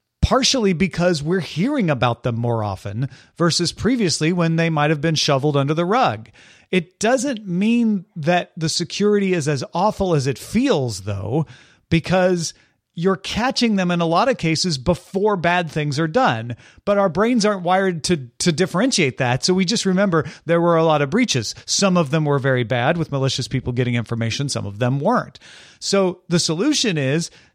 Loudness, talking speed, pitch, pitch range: -19 LUFS, 185 wpm, 170 Hz, 140-195 Hz